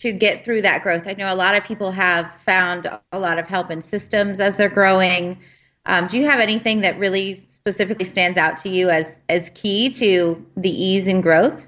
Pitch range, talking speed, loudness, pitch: 175-205 Hz, 215 wpm, -18 LUFS, 190 Hz